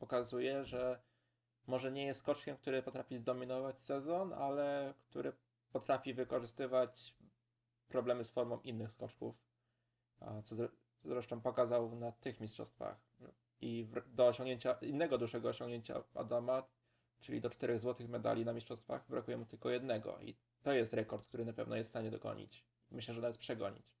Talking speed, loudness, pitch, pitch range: 150 wpm, -42 LUFS, 120 Hz, 115-130 Hz